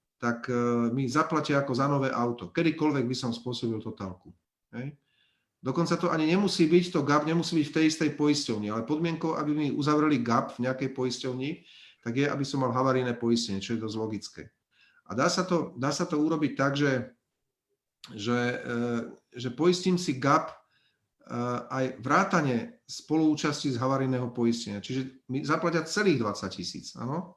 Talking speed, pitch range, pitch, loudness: 160 wpm, 120-155 Hz, 135 Hz, -28 LUFS